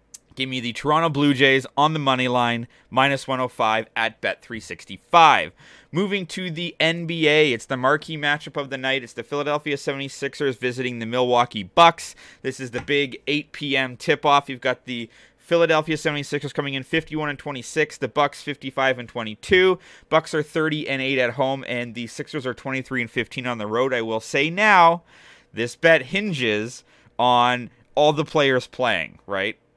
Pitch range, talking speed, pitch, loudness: 125-155 Hz, 170 wpm, 135 Hz, -21 LUFS